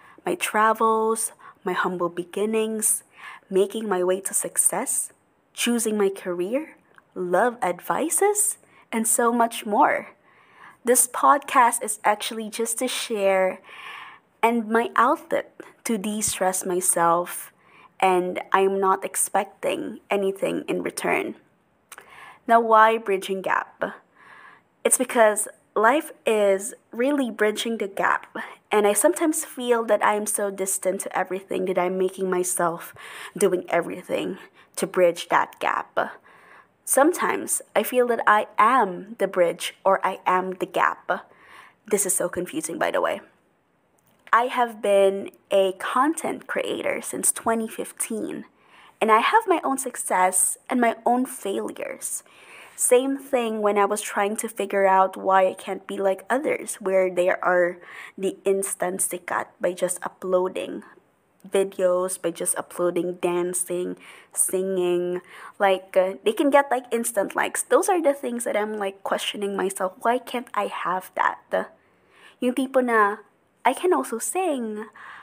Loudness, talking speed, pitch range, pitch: -23 LUFS, 135 wpm, 185-240 Hz, 205 Hz